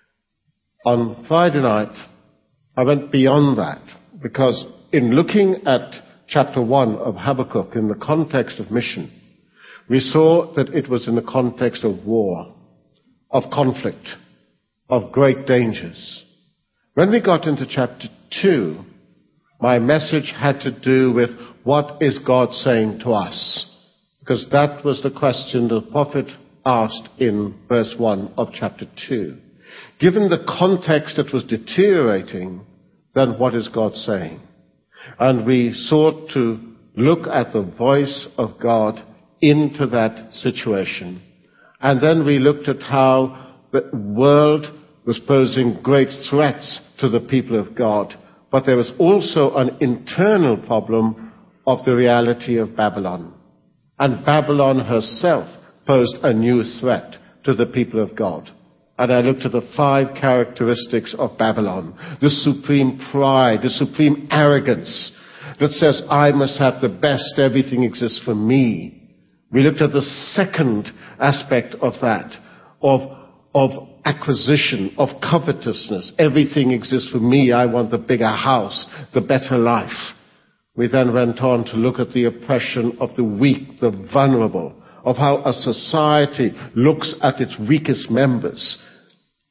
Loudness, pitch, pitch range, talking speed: -18 LUFS, 130 Hz, 120-140 Hz, 140 wpm